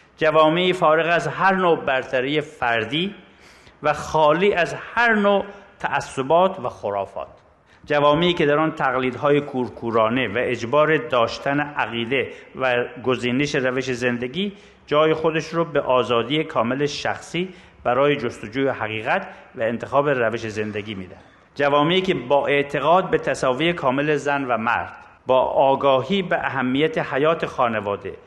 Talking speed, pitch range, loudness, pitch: 125 wpm, 125-160 Hz, -21 LUFS, 145 Hz